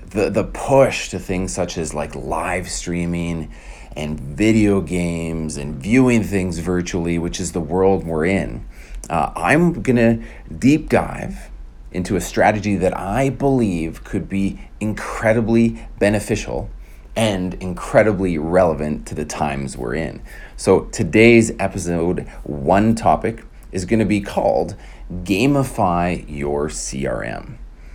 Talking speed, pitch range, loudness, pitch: 130 wpm, 80-110 Hz, -19 LUFS, 90 Hz